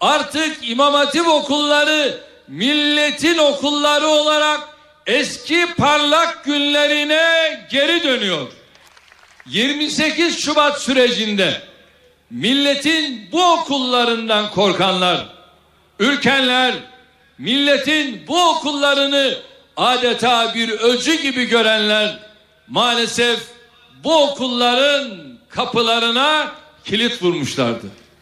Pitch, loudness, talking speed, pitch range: 280 Hz, -16 LUFS, 70 wpm, 235-300 Hz